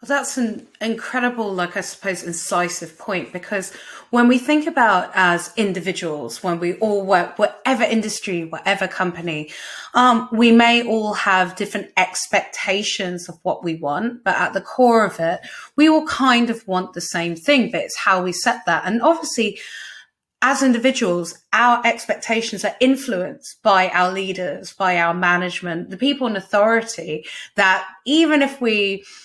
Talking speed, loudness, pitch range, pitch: 160 wpm, -19 LUFS, 180-235 Hz, 200 Hz